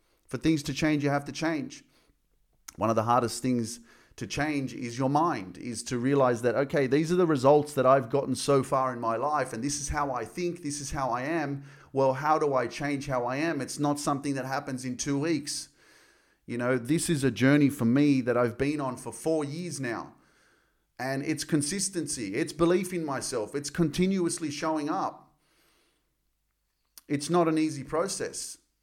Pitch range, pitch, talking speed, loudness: 130-155 Hz, 145 Hz, 195 wpm, -28 LUFS